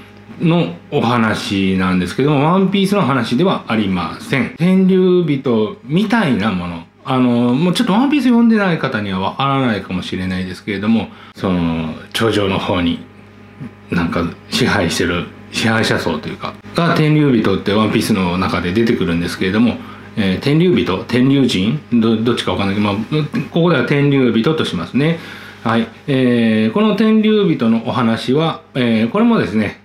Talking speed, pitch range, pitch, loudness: 350 characters per minute, 100-155 Hz, 115 Hz, -15 LUFS